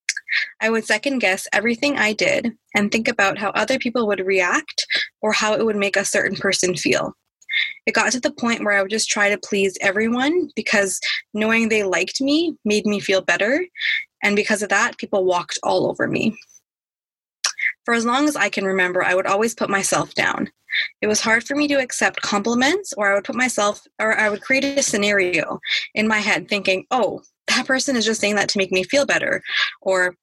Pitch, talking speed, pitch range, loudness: 215 Hz, 205 wpm, 200-265 Hz, -19 LUFS